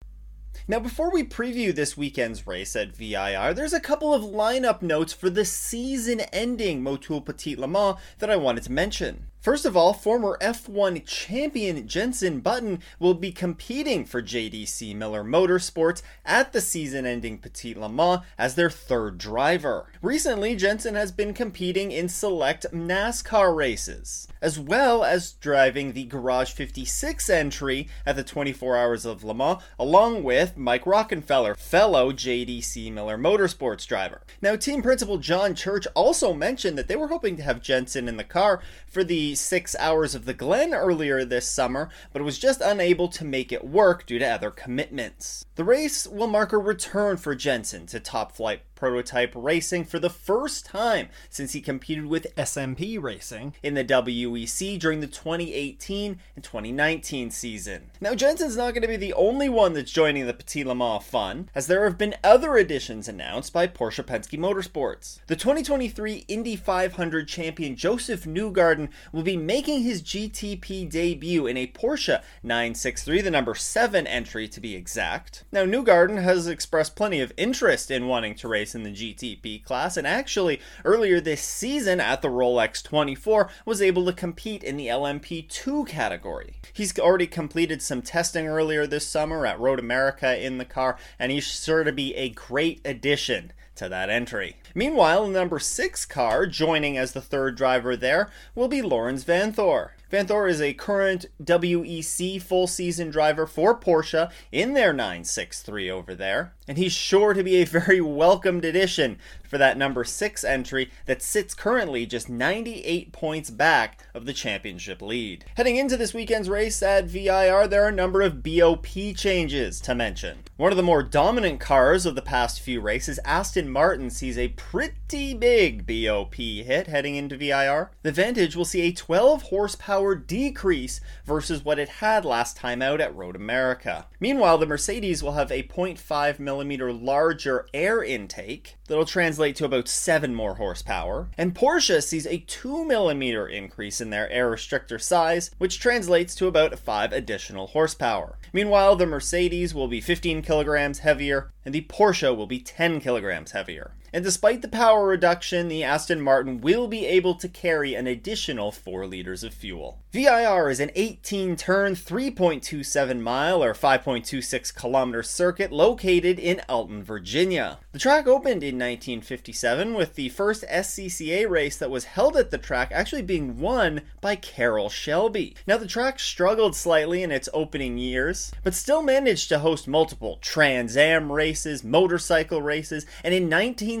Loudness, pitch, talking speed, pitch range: -24 LUFS, 165 Hz, 165 wpm, 135-195 Hz